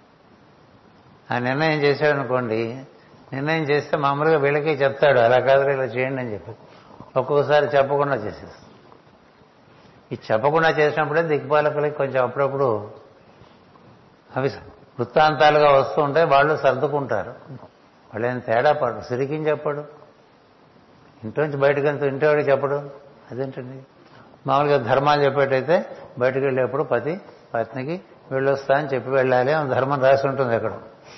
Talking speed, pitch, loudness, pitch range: 110 wpm, 140 Hz, -21 LUFS, 130-150 Hz